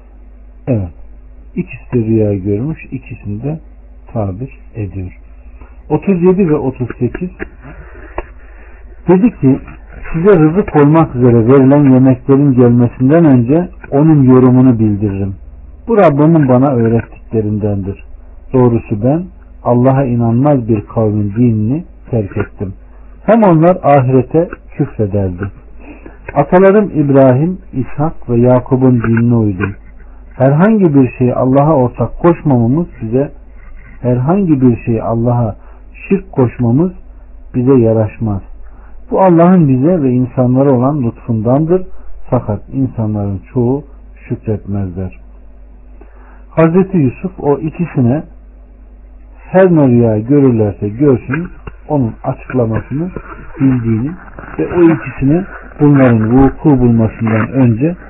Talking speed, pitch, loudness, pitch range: 95 wpm, 125 Hz, -11 LUFS, 105-145 Hz